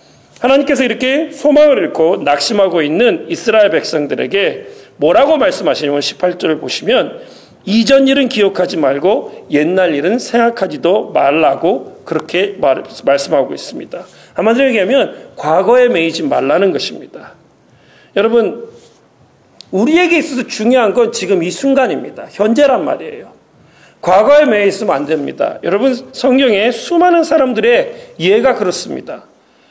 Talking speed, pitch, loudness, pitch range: 320 characters per minute, 255 Hz, -12 LUFS, 205-295 Hz